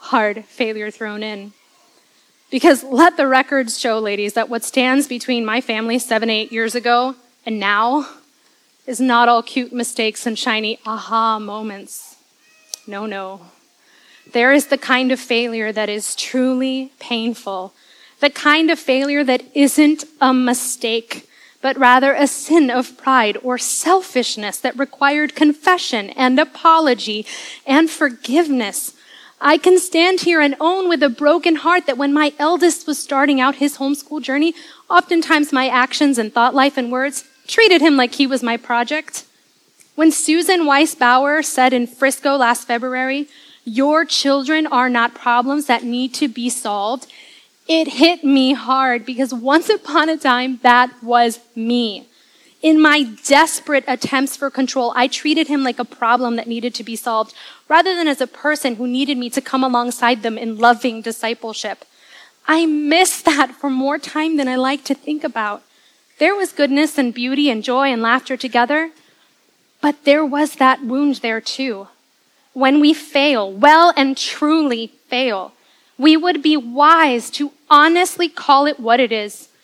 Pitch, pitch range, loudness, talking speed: 265 Hz, 240-300 Hz, -16 LUFS, 160 wpm